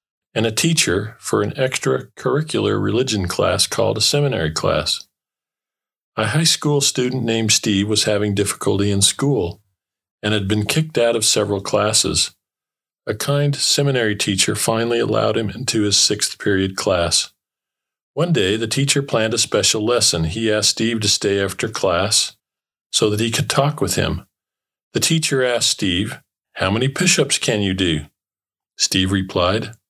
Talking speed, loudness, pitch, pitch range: 155 wpm, -18 LUFS, 110 Hz, 100-135 Hz